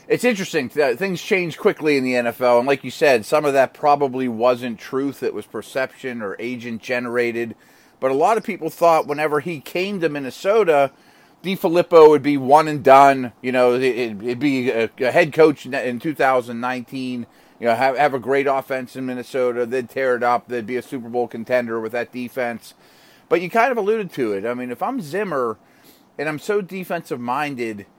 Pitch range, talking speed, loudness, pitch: 125-160 Hz, 185 wpm, -19 LUFS, 135 Hz